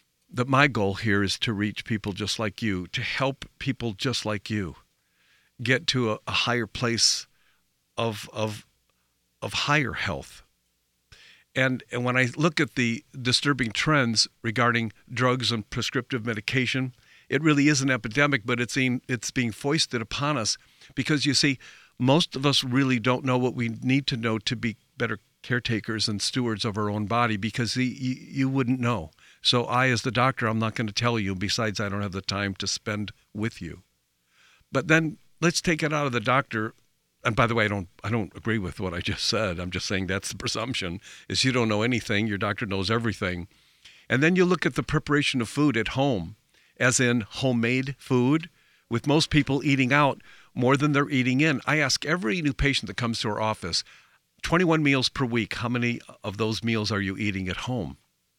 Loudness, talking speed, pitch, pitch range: -25 LUFS, 200 wpm, 120 Hz, 105-135 Hz